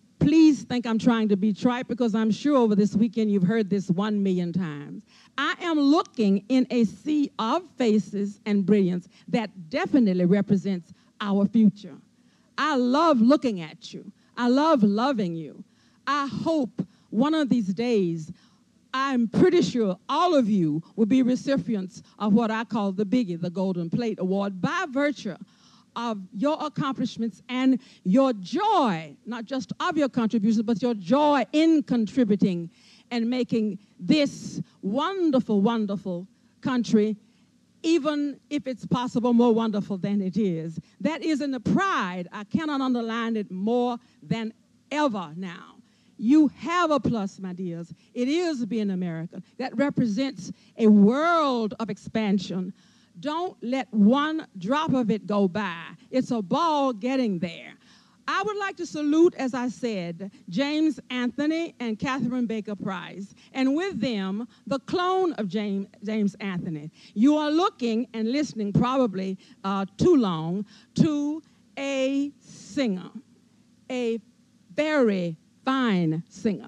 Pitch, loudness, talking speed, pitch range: 225 Hz, -25 LUFS, 140 wpm, 200-265 Hz